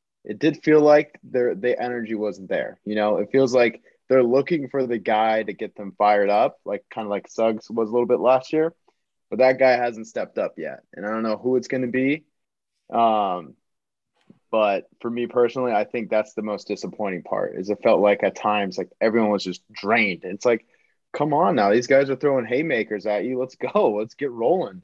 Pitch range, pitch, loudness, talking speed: 105-130 Hz, 120 Hz, -22 LUFS, 215 wpm